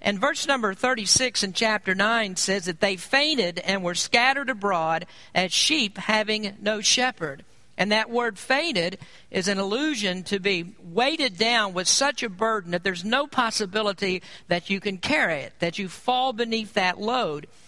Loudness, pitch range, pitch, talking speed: -23 LUFS, 185-240 Hz, 205 Hz, 170 wpm